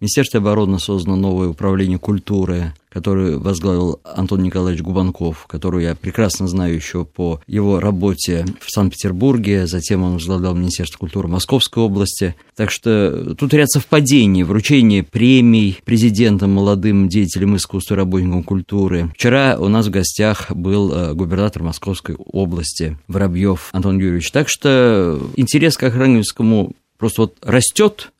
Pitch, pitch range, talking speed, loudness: 95 Hz, 90-110 Hz, 130 wpm, -16 LUFS